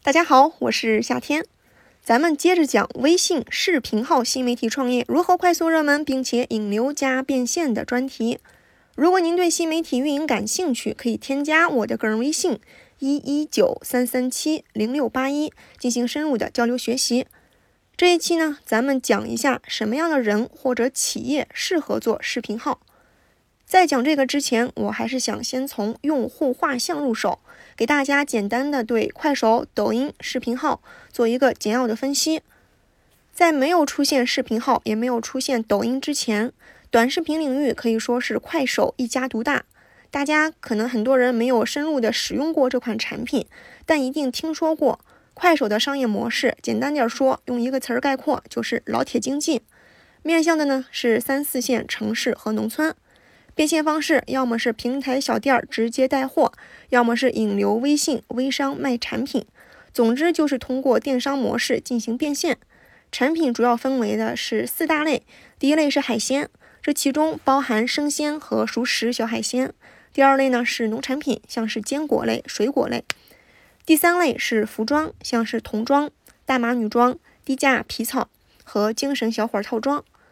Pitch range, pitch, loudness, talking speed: 235-295 Hz, 260 Hz, -21 LUFS, 260 characters per minute